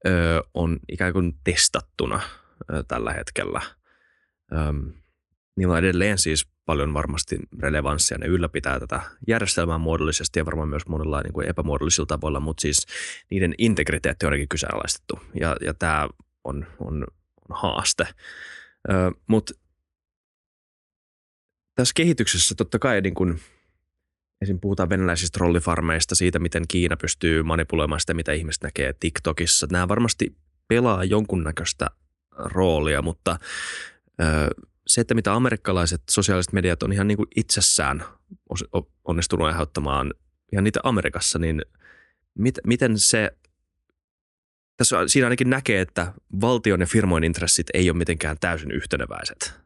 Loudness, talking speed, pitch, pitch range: -23 LUFS, 120 wpm, 85 Hz, 75-95 Hz